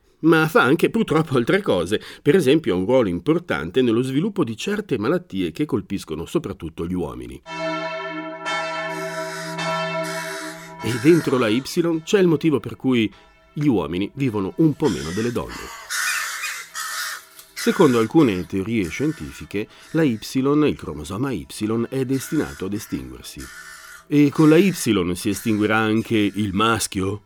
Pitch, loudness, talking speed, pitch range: 135 Hz, -21 LUFS, 135 wpm, 105-165 Hz